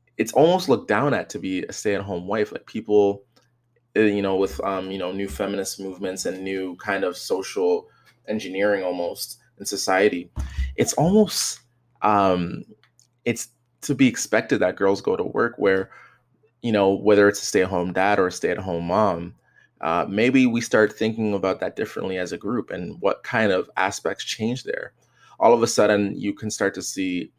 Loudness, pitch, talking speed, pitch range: -23 LUFS, 100 Hz, 180 wpm, 95-120 Hz